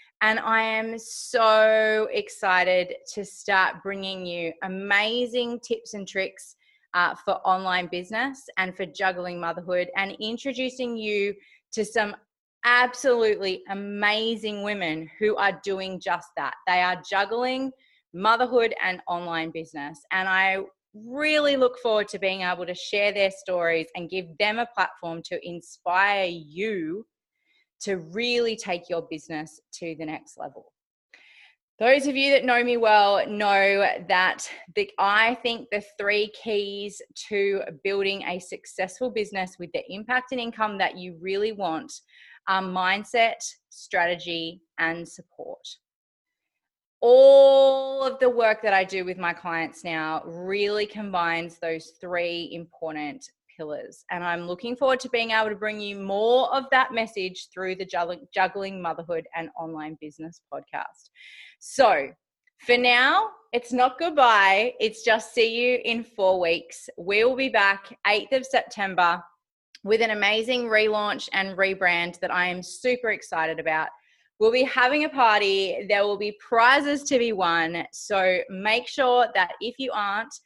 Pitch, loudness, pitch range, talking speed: 205 Hz, -24 LUFS, 180-240 Hz, 145 wpm